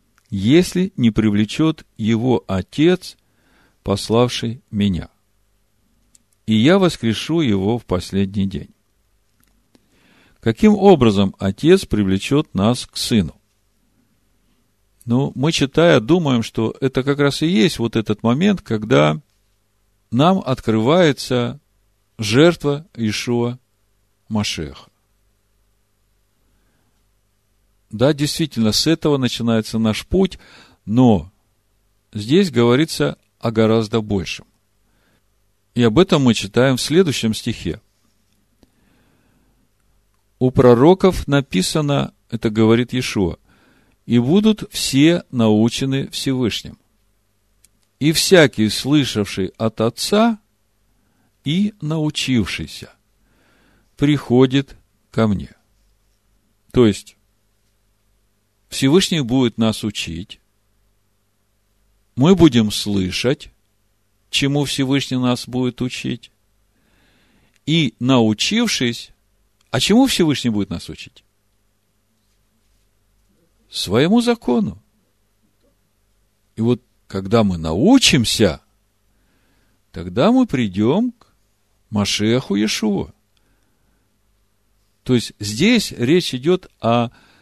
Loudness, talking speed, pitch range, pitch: -17 LUFS, 85 wpm, 105-130 Hz, 110 Hz